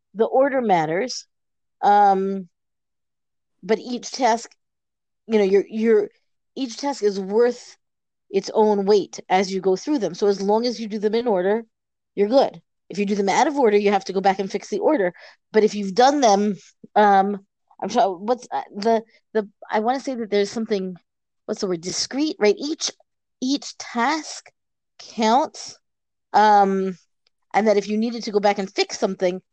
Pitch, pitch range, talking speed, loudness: 210 Hz, 195-235 Hz, 185 wpm, -21 LUFS